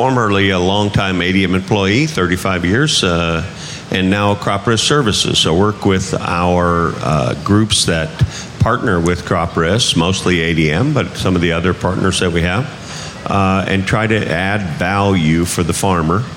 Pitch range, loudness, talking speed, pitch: 90-105 Hz, -14 LUFS, 160 wpm, 95 Hz